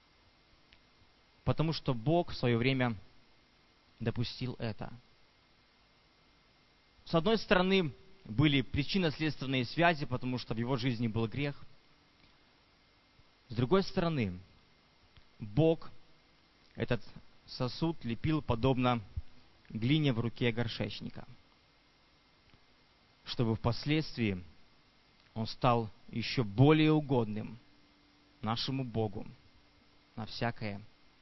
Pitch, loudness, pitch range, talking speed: 120 Hz, -33 LUFS, 110-145 Hz, 85 wpm